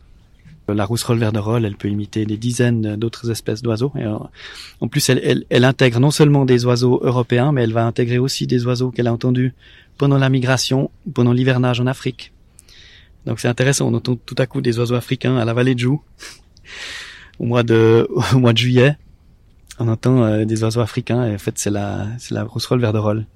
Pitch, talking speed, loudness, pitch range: 120 Hz, 195 wpm, -17 LUFS, 110-130 Hz